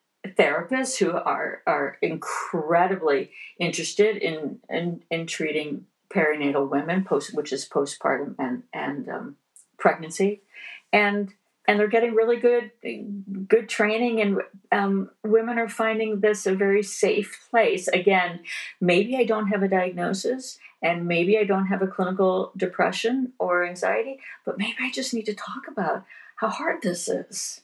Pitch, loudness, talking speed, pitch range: 200 Hz, -24 LUFS, 145 wpm, 175-220 Hz